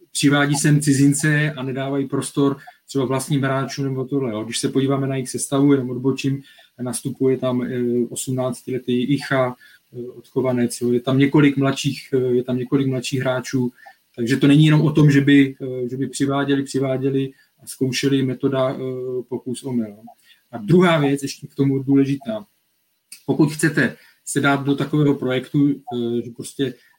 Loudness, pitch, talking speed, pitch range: -20 LUFS, 135 Hz, 150 wpm, 130-140 Hz